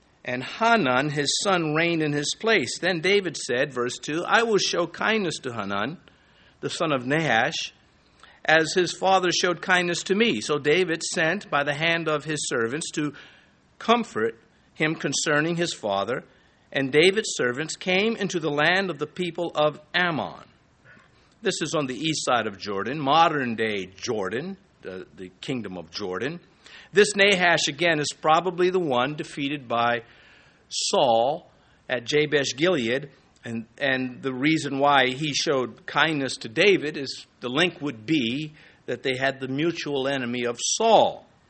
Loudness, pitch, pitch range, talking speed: -24 LUFS, 150 Hz, 135-175 Hz, 160 wpm